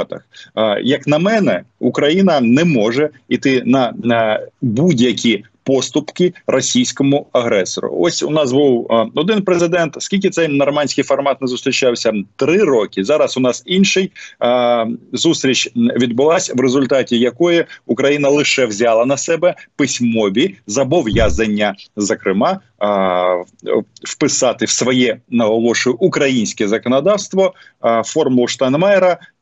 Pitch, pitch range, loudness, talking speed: 135 Hz, 120-170 Hz, -15 LUFS, 110 wpm